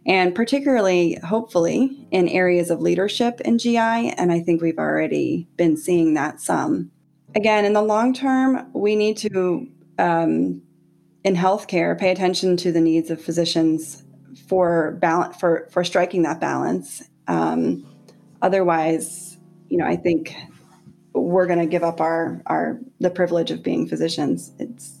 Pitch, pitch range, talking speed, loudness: 175 Hz, 165-200 Hz, 150 wpm, -20 LUFS